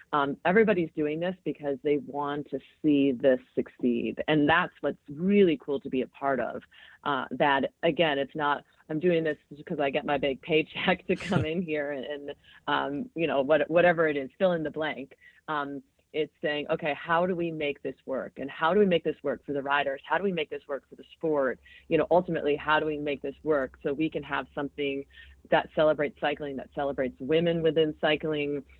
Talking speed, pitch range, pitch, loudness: 215 wpm, 140-165 Hz, 150 Hz, -28 LUFS